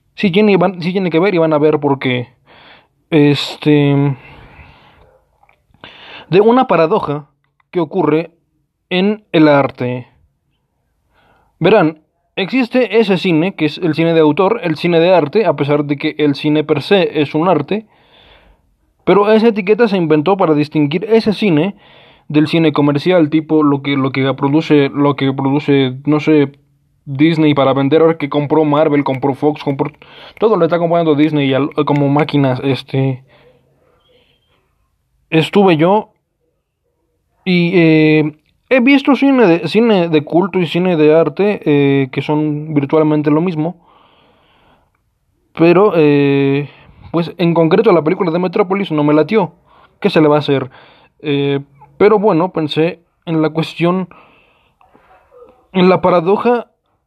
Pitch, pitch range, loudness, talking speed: 155 Hz, 145-180 Hz, -13 LUFS, 145 wpm